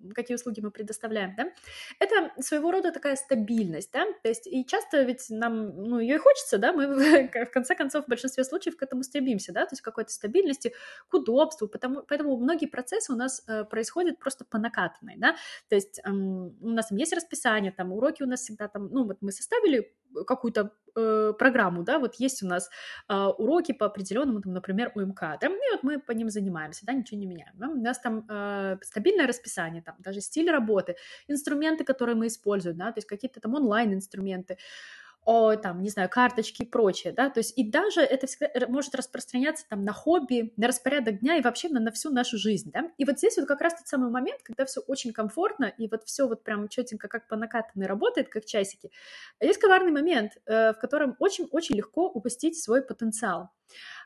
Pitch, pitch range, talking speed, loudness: 245 Hz, 215-285 Hz, 200 wpm, -28 LUFS